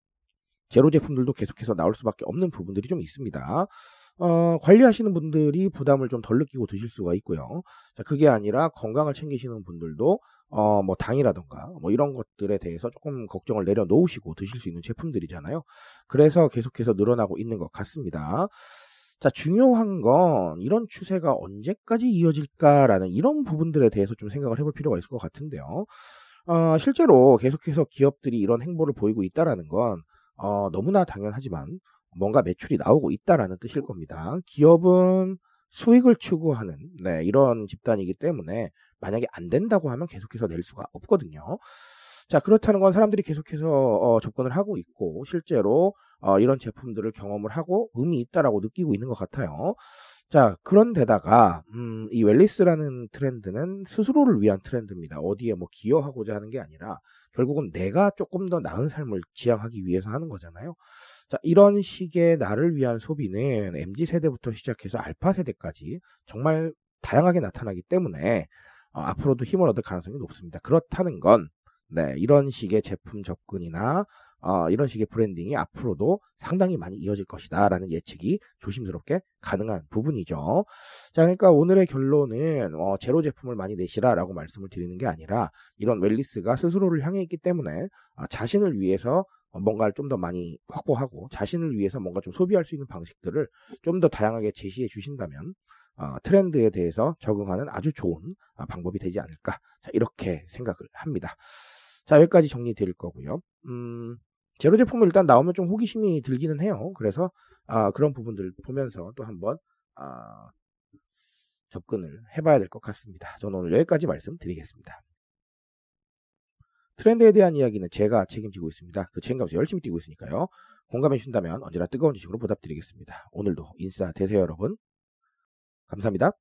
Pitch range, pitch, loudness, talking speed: 100-170 Hz, 130 Hz, -24 LUFS, 375 characters per minute